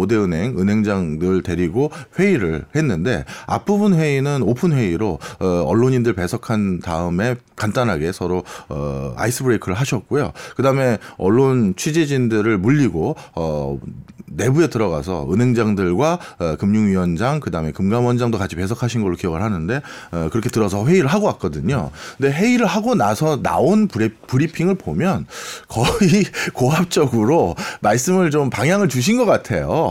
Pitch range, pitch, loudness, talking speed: 95-150 Hz, 120 Hz, -18 LUFS, 325 characters per minute